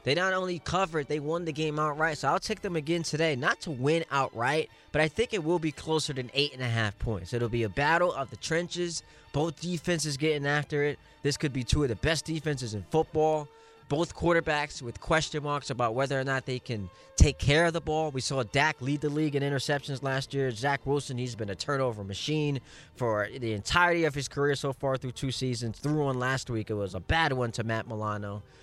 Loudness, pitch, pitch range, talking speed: -29 LUFS, 145 Hz, 130-155 Hz, 230 wpm